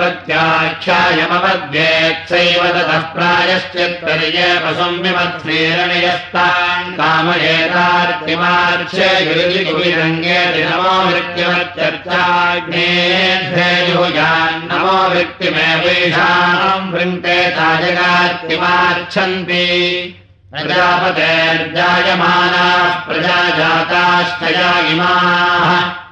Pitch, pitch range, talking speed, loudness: 175 Hz, 165-180 Hz, 30 wpm, -12 LUFS